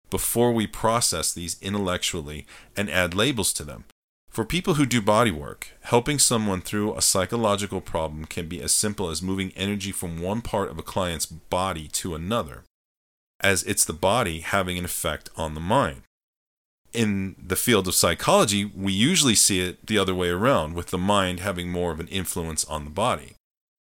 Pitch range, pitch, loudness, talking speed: 85-105 Hz, 95 Hz, -24 LUFS, 180 wpm